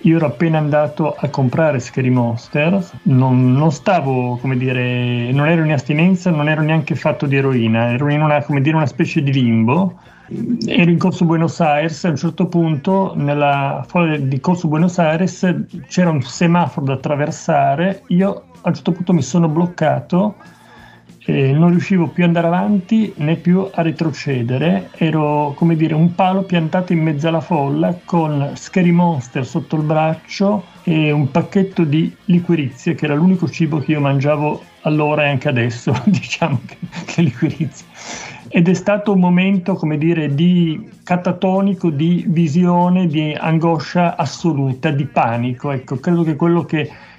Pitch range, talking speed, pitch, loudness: 145-175 Hz, 165 wpm, 160 Hz, -16 LUFS